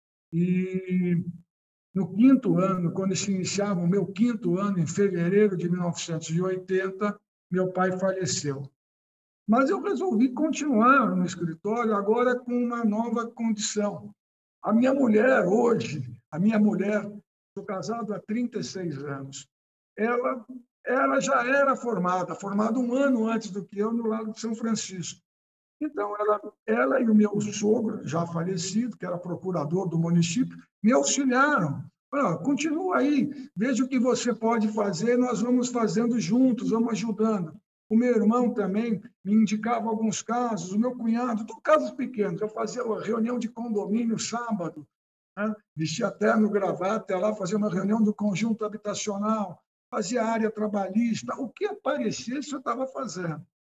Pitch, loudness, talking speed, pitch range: 215 Hz, -26 LUFS, 150 wpm, 185-235 Hz